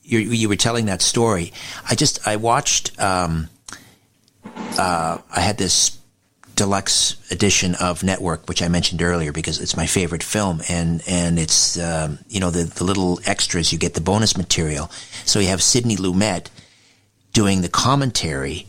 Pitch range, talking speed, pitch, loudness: 85-105 Hz, 165 wpm, 95 Hz, -19 LUFS